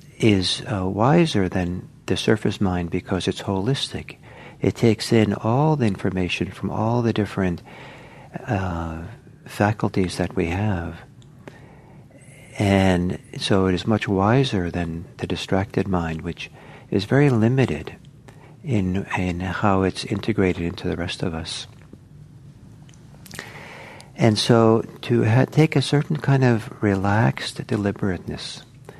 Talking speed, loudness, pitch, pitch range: 125 wpm, -22 LUFS, 110 Hz, 95-135 Hz